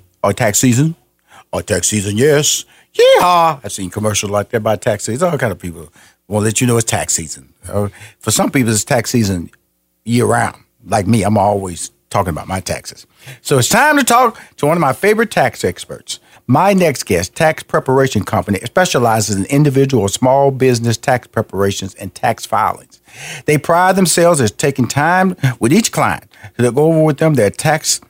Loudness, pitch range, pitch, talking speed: -14 LUFS, 105-150 Hz, 120 Hz, 195 wpm